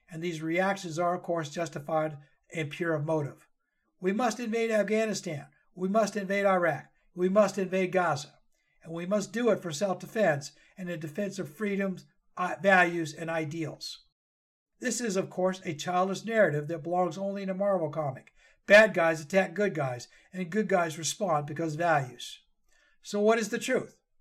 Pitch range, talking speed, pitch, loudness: 165-205 Hz, 170 wpm, 180 Hz, -29 LUFS